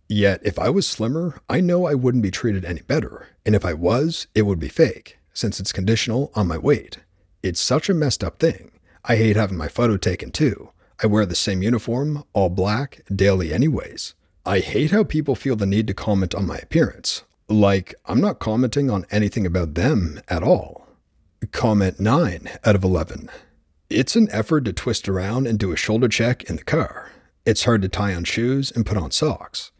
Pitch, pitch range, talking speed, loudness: 105 Hz, 95-125 Hz, 200 wpm, -21 LUFS